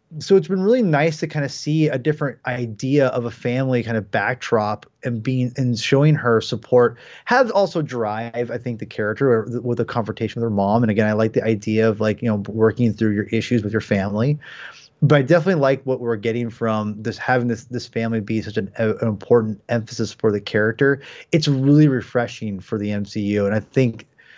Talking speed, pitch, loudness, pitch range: 215 wpm, 120 Hz, -20 LUFS, 110-135 Hz